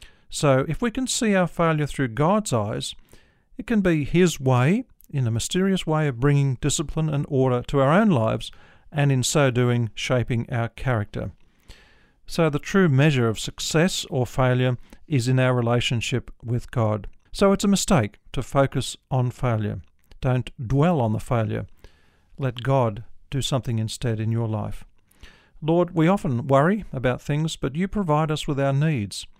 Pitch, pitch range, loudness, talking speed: 130 Hz, 115-155 Hz, -23 LUFS, 170 wpm